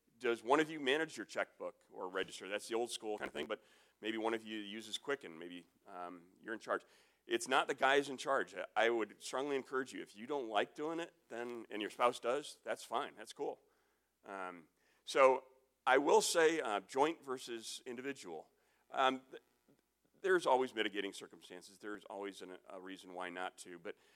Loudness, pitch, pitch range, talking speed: -38 LUFS, 125 Hz, 100-140 Hz, 195 wpm